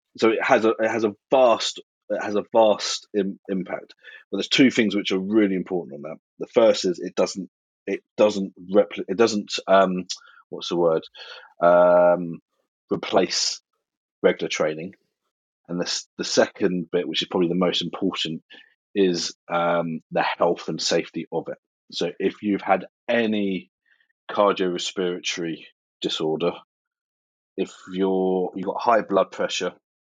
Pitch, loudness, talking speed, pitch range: 95 Hz, -23 LUFS, 150 wpm, 90-105 Hz